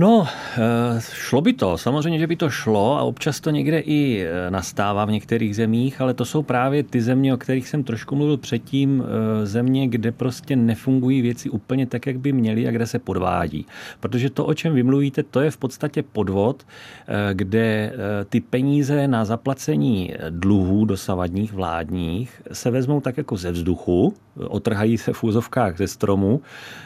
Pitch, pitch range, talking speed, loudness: 120 Hz, 105-135 Hz, 165 wpm, -21 LUFS